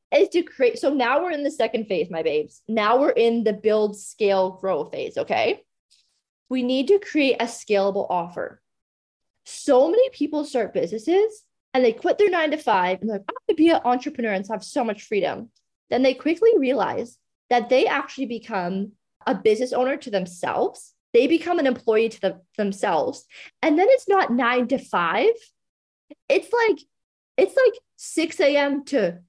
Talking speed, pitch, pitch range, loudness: 180 wpm, 255 Hz, 220-330 Hz, -22 LUFS